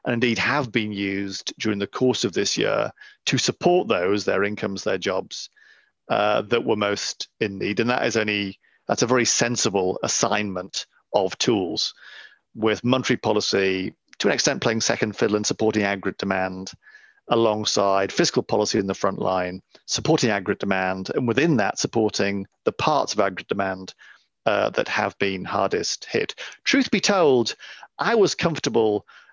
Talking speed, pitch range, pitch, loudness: 160 wpm, 95-120 Hz, 105 Hz, -23 LUFS